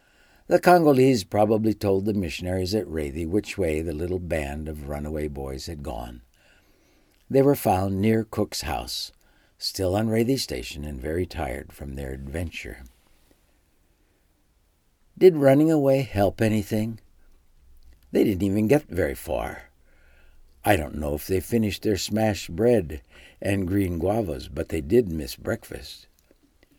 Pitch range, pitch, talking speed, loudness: 75-110 Hz, 90 Hz, 140 wpm, -24 LUFS